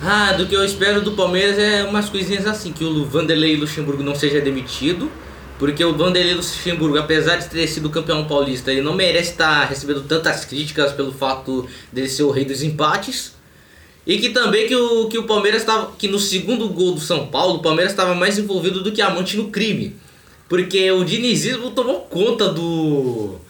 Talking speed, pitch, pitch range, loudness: 195 wpm, 175 Hz, 150-200 Hz, -18 LUFS